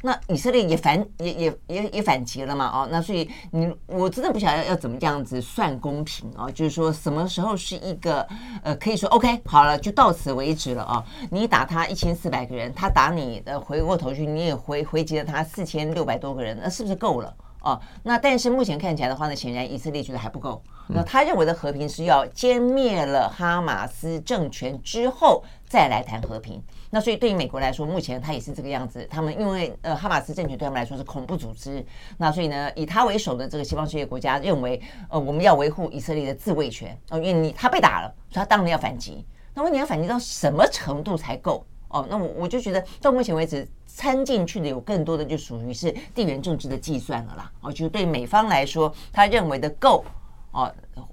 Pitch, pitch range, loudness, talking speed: 160 Hz, 140-190 Hz, -24 LUFS, 345 characters per minute